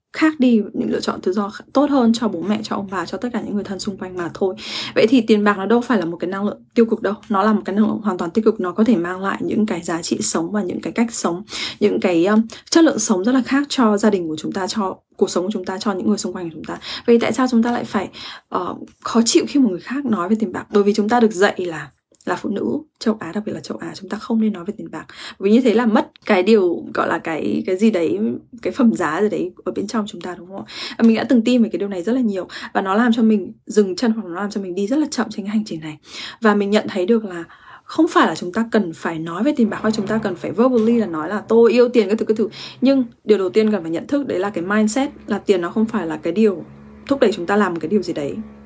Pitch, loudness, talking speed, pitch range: 215 Hz, -19 LUFS, 320 wpm, 190-235 Hz